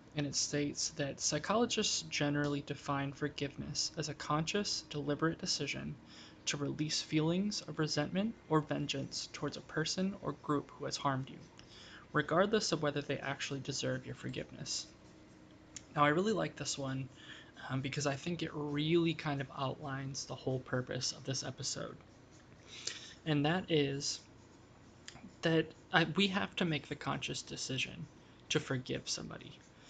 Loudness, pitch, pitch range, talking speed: -36 LUFS, 145 Hz, 135-160 Hz, 145 wpm